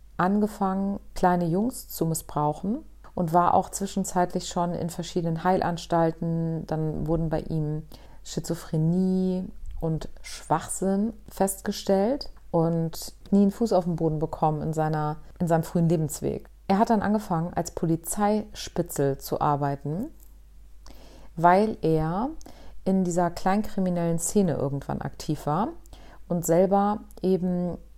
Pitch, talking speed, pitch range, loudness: 175 Hz, 120 wpm, 160-195 Hz, -26 LUFS